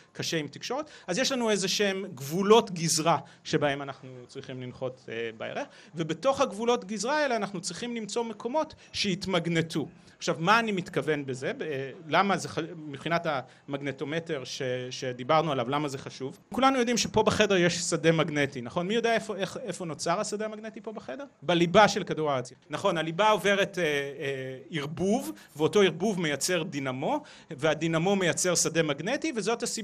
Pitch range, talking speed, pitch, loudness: 145-215 Hz, 165 wpm, 170 Hz, -28 LUFS